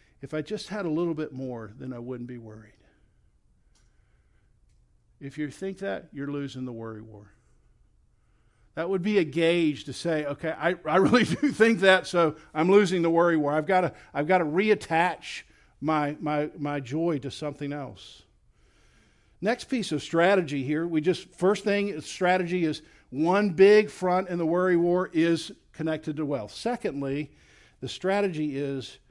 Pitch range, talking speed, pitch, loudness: 140-185 Hz, 170 wpm, 155 Hz, -26 LUFS